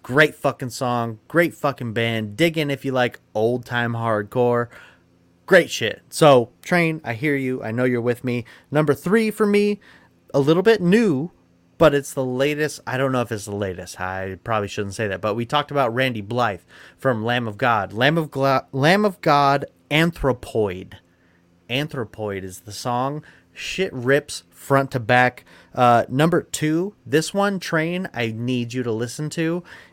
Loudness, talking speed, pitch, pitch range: -21 LUFS, 175 wpm, 130 Hz, 115-150 Hz